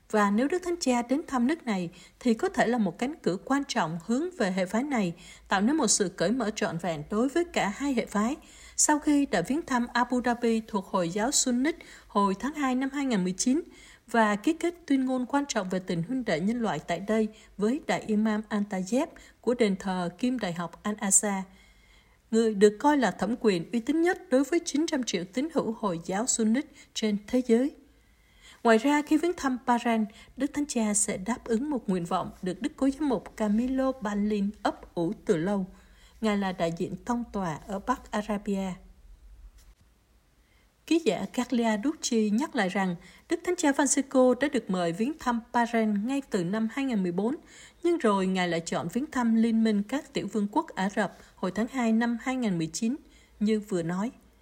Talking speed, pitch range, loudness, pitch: 200 wpm, 200-265 Hz, -28 LUFS, 225 Hz